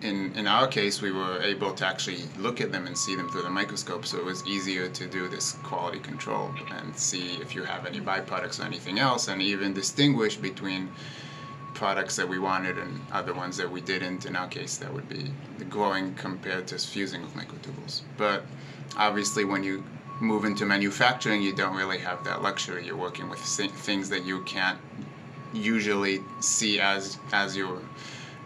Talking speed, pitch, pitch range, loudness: 190 wpm, 100 Hz, 95-130 Hz, -29 LUFS